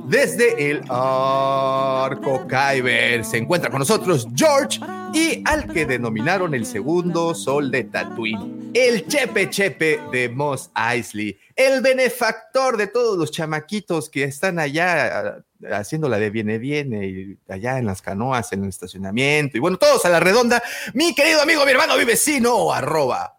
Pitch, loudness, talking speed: 155 Hz, -19 LUFS, 155 wpm